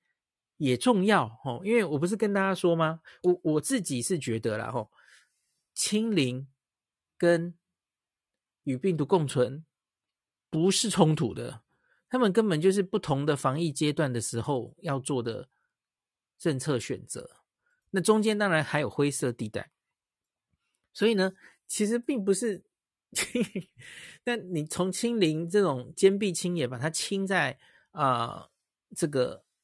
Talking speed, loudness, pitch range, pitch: 195 characters per minute, -28 LUFS, 145-205 Hz, 170 Hz